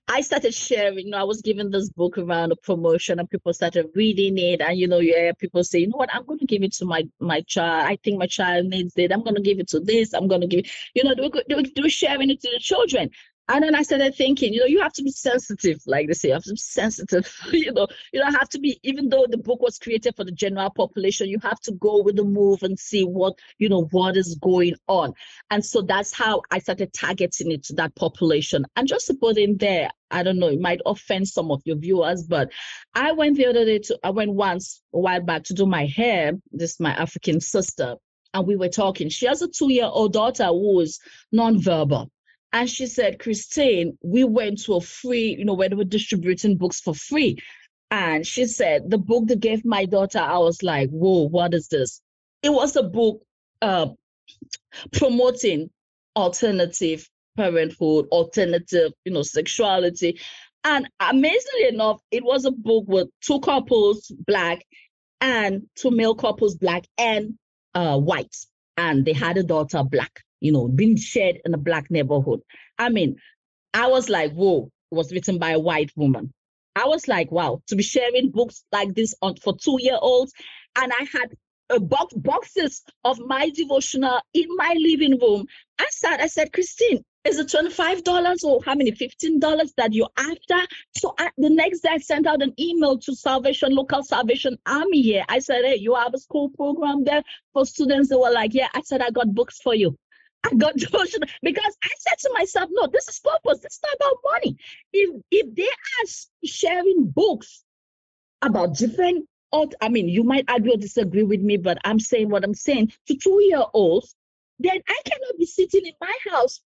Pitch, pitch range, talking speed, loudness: 220 Hz, 180-275 Hz, 205 wpm, -21 LUFS